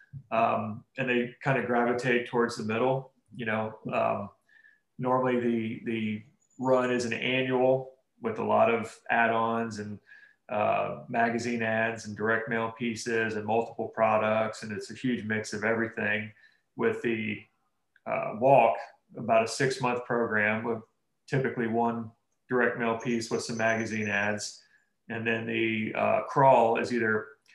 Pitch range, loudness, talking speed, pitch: 110-120 Hz, -28 LUFS, 150 wpm, 115 Hz